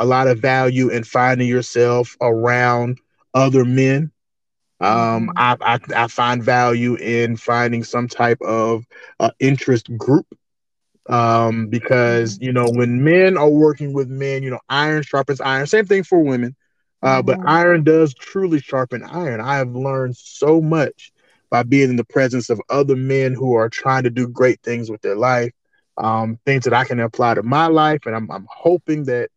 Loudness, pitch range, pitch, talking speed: -17 LUFS, 120-140 Hz, 125 Hz, 180 wpm